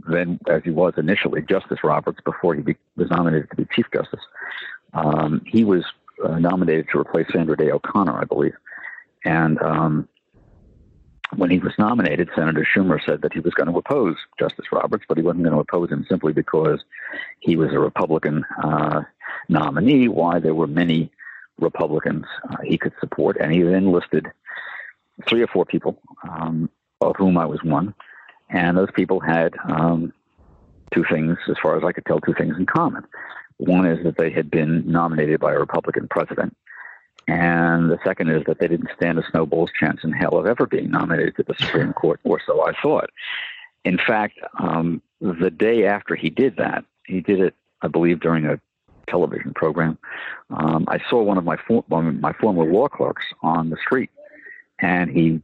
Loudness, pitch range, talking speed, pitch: -20 LUFS, 80-90 Hz, 185 wpm, 85 Hz